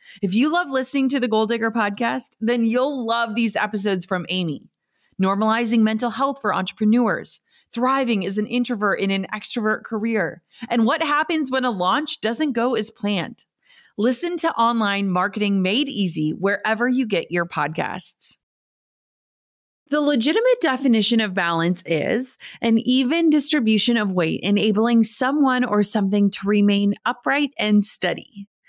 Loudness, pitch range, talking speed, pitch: -20 LUFS, 205-255 Hz, 145 wpm, 225 Hz